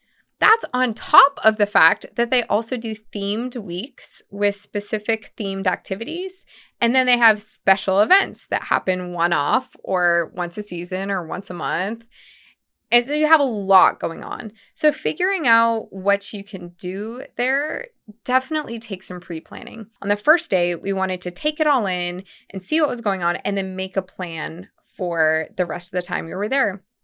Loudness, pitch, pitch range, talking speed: -21 LUFS, 205 Hz, 185-245 Hz, 195 wpm